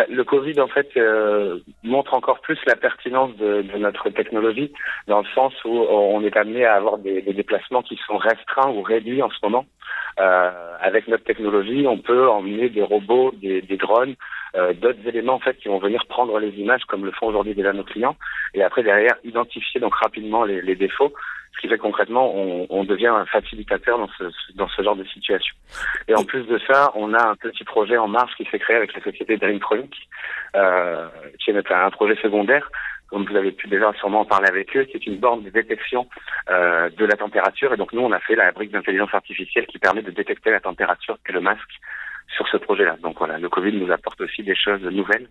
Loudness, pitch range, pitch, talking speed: -20 LUFS, 100-140 Hz, 115 Hz, 220 wpm